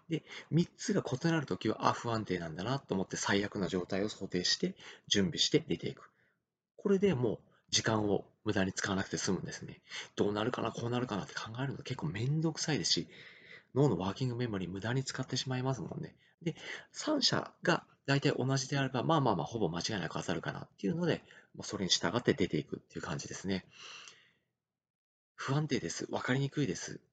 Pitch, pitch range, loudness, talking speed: 125 Hz, 100-150 Hz, -34 LUFS, 405 characters per minute